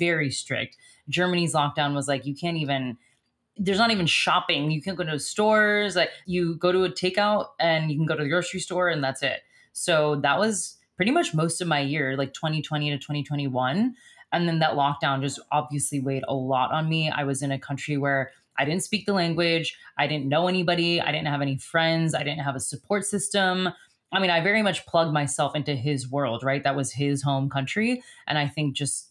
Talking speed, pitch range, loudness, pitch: 215 wpm, 140-180 Hz, -25 LUFS, 150 Hz